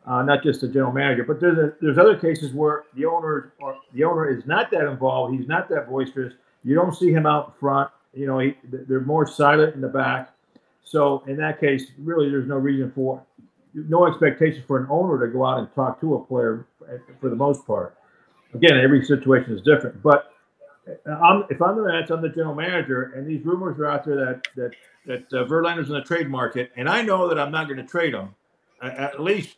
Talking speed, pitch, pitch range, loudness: 225 wpm, 145 Hz, 130-160 Hz, -21 LUFS